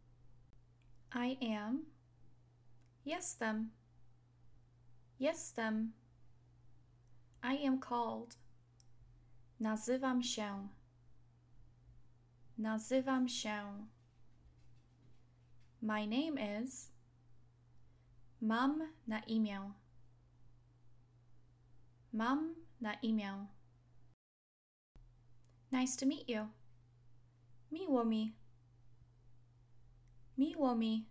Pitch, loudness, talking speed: 120 Hz, -40 LUFS, 60 wpm